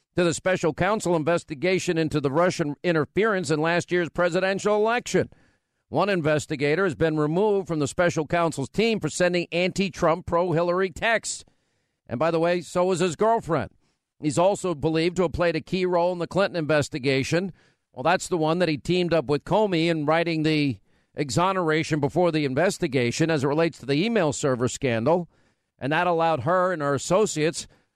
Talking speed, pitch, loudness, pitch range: 180 wpm, 170 Hz, -24 LUFS, 155-180 Hz